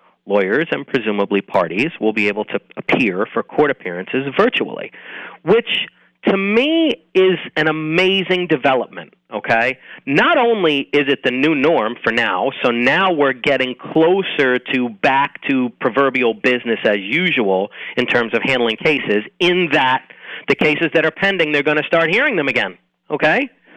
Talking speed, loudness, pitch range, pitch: 155 wpm, -16 LUFS, 125-180 Hz, 145 Hz